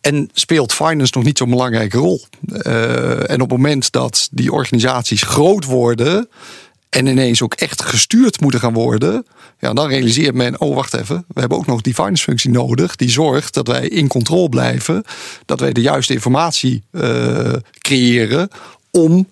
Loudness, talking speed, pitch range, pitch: -15 LUFS, 175 wpm, 120-155 Hz, 130 Hz